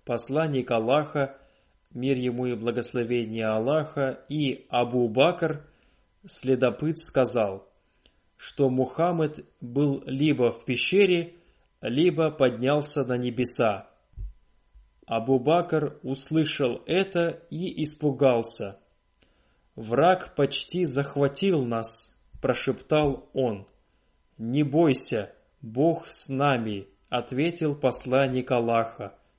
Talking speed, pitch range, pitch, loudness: 85 wpm, 120-155 Hz, 135 Hz, -26 LUFS